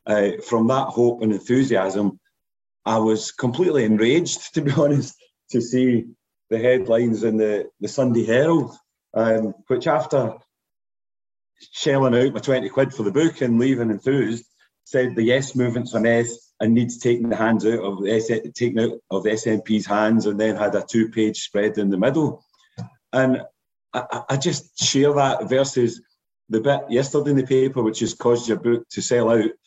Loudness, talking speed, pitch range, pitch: -21 LUFS, 175 wpm, 110-130 Hz, 115 Hz